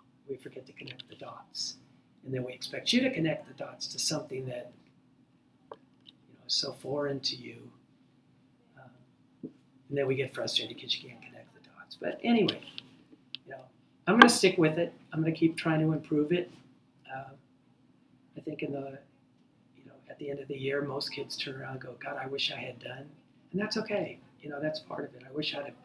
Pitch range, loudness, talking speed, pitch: 130-160 Hz, -31 LUFS, 215 wpm, 145 Hz